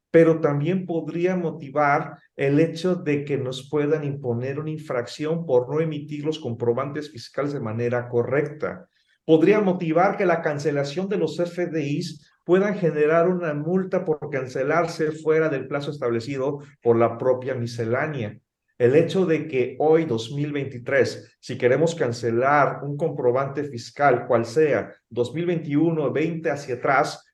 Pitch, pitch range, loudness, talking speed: 150 Hz, 135-165 Hz, -23 LUFS, 135 wpm